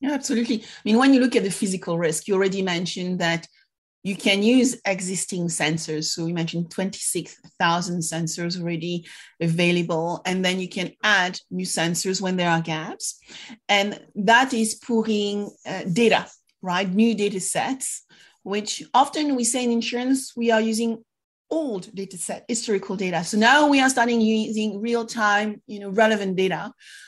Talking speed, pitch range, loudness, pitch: 165 wpm, 175-230 Hz, -22 LUFS, 200 Hz